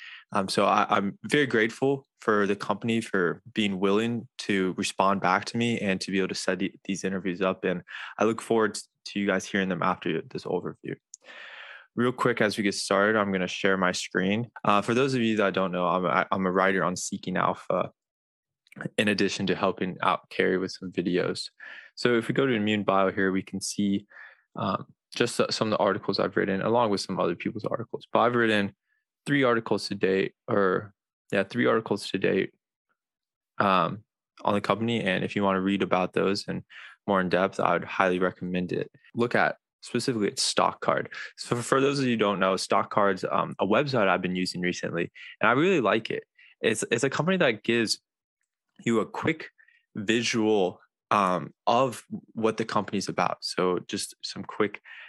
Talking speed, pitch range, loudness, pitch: 200 wpm, 95-120 Hz, -26 LUFS, 105 Hz